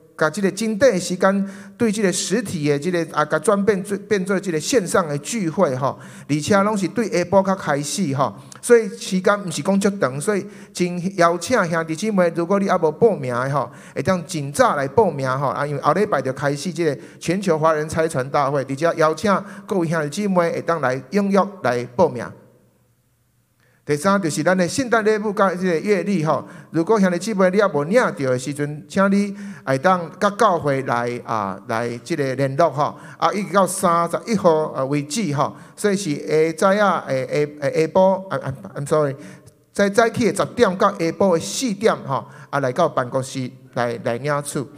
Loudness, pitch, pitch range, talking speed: -20 LUFS, 170 Hz, 145-200 Hz, 285 characters per minute